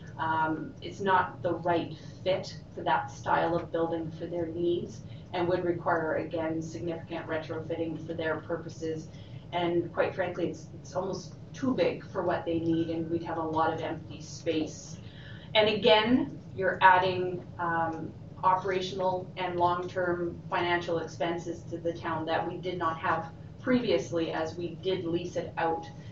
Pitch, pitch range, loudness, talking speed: 165 Hz, 160-180 Hz, -30 LUFS, 160 wpm